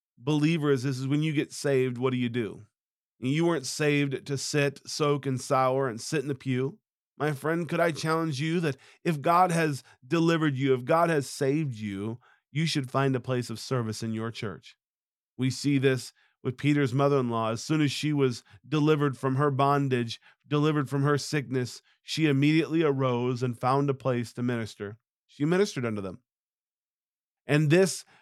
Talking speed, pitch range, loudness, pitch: 185 wpm, 125-150 Hz, -27 LUFS, 140 Hz